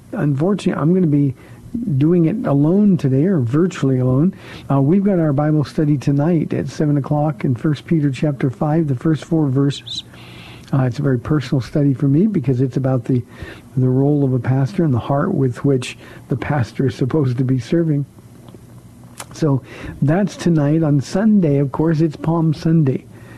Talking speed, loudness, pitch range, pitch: 180 wpm, -17 LUFS, 135-160 Hz, 145 Hz